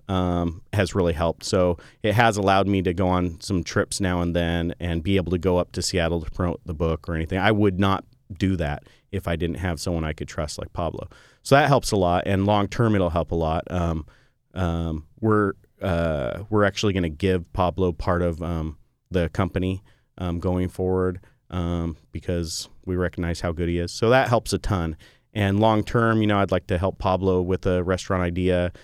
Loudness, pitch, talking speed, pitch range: -24 LUFS, 90 Hz, 215 wpm, 85-100 Hz